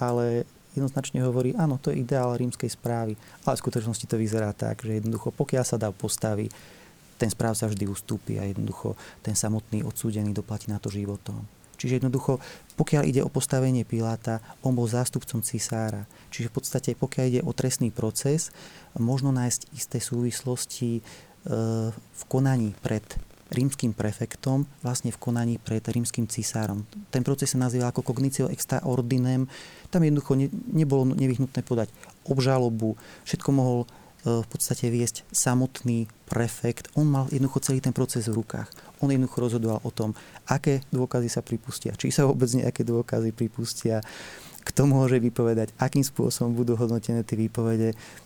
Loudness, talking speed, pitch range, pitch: -27 LUFS, 155 wpm, 115-130 Hz, 120 Hz